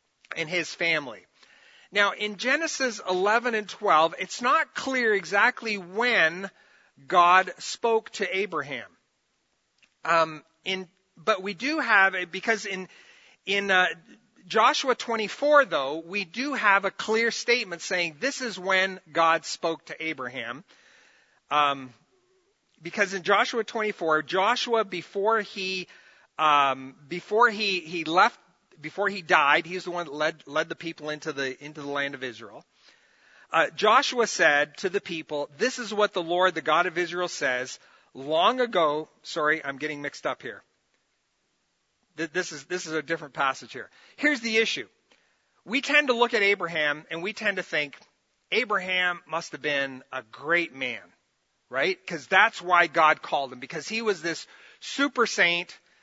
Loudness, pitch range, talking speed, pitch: -25 LUFS, 160-220 Hz, 155 wpm, 185 Hz